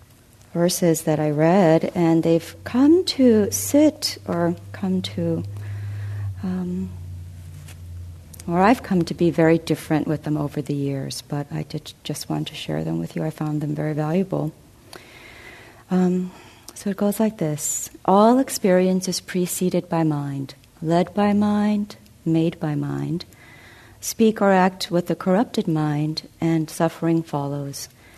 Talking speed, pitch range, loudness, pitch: 145 wpm, 120-180 Hz, -22 LUFS, 155 Hz